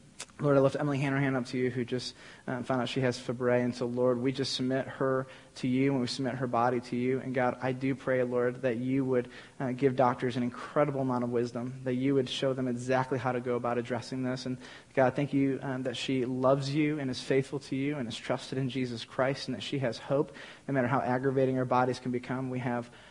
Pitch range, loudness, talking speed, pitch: 125-135 Hz, -31 LUFS, 255 wpm, 130 Hz